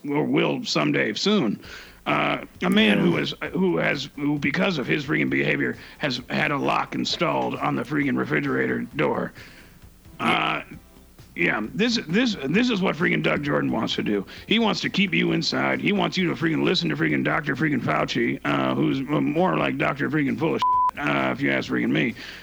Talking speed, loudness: 185 wpm, -23 LUFS